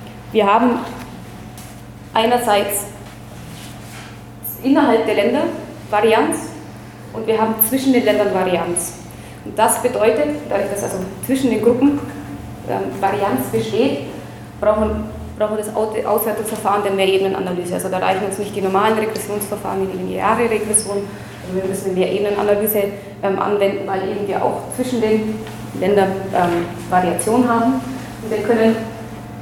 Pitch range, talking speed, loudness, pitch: 185-220 Hz, 130 wpm, -18 LUFS, 205 Hz